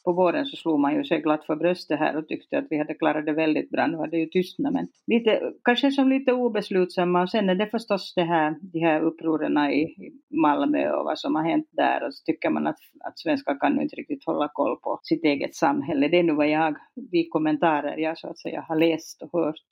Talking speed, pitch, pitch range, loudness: 245 wpm, 180 Hz, 160-265 Hz, -24 LUFS